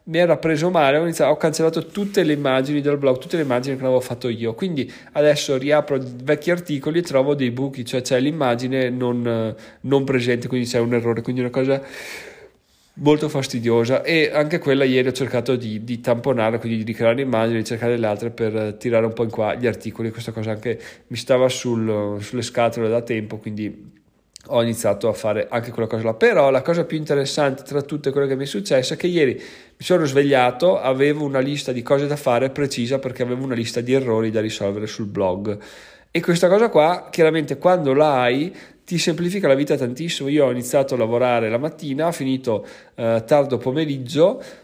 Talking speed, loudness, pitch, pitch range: 200 wpm, -20 LUFS, 130 Hz, 115-150 Hz